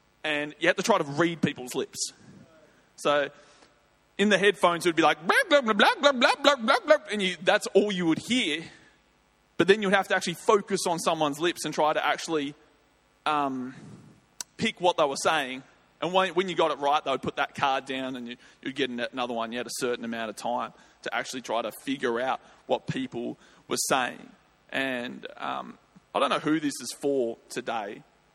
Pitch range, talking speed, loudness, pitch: 135-195 Hz, 210 wpm, -26 LUFS, 160 Hz